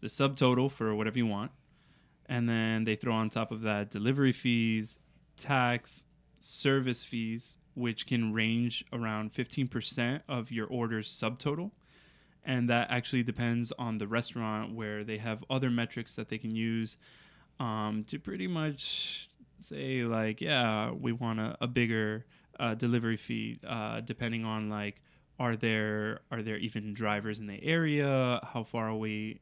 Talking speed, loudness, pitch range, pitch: 155 wpm, -33 LUFS, 110-125 Hz, 115 Hz